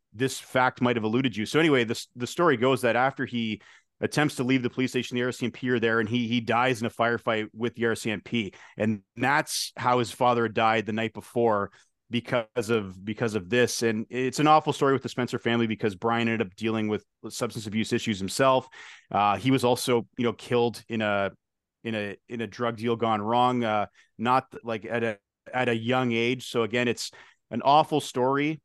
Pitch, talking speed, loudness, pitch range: 120 Hz, 210 wpm, -26 LUFS, 110-125 Hz